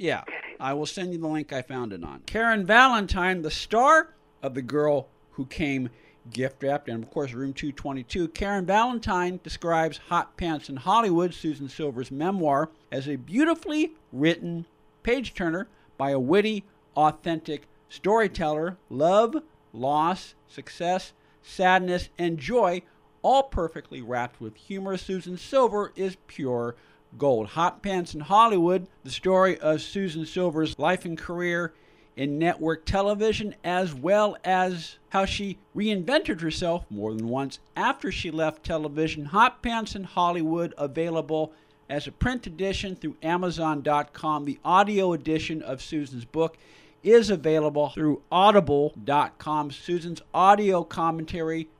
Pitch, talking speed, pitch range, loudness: 165 Hz, 135 wpm, 145-190 Hz, -26 LUFS